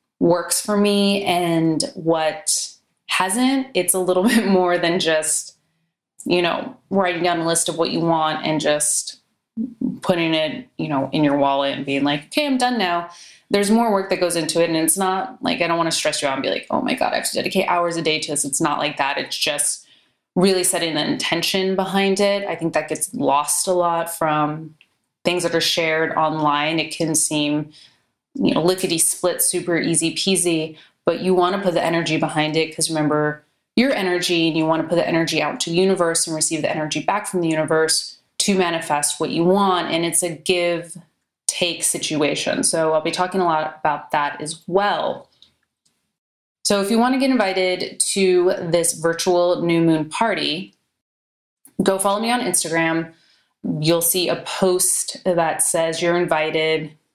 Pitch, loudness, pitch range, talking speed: 170 Hz, -19 LUFS, 155-185 Hz, 195 wpm